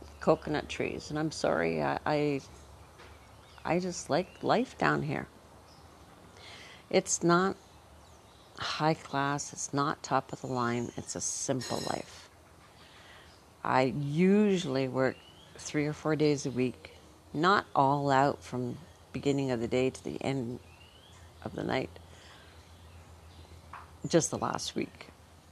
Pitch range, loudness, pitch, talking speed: 85-140 Hz, -31 LUFS, 120 Hz, 125 wpm